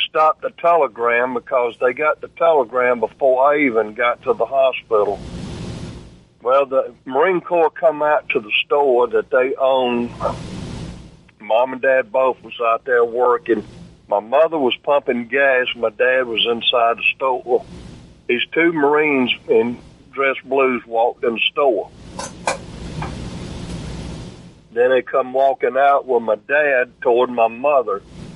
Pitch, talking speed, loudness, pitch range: 130 Hz, 140 wpm, -17 LUFS, 120-145 Hz